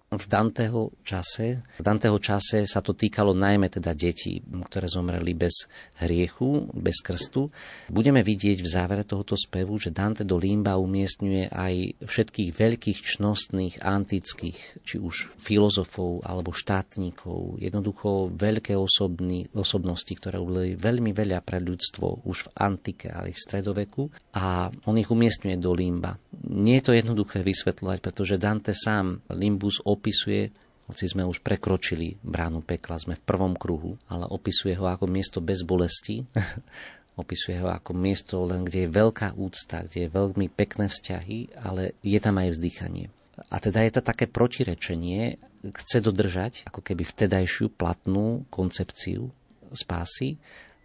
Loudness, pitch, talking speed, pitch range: -26 LUFS, 100 Hz, 145 wpm, 90-105 Hz